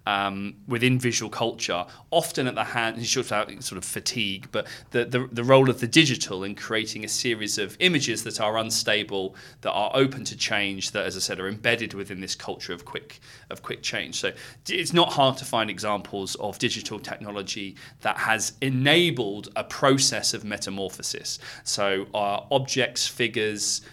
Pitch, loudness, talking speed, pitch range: 110 Hz, -25 LUFS, 170 wpm, 100-125 Hz